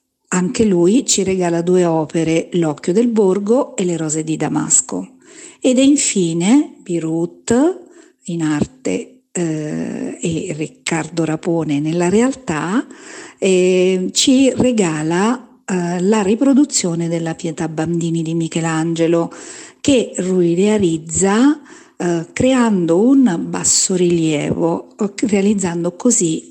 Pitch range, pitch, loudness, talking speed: 165-250 Hz, 185 Hz, -16 LUFS, 105 wpm